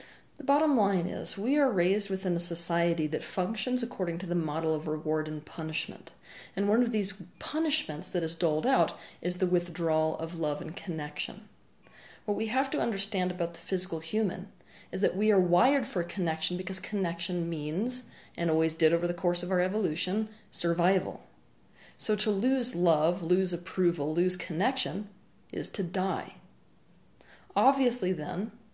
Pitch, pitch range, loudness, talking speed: 180 Hz, 170-210 Hz, -30 LUFS, 165 wpm